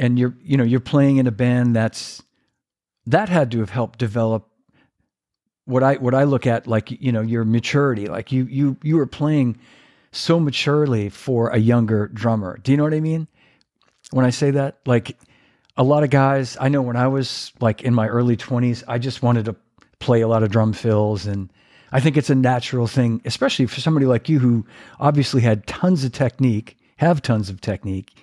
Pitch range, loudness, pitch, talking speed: 115-135 Hz, -19 LUFS, 125 Hz, 205 wpm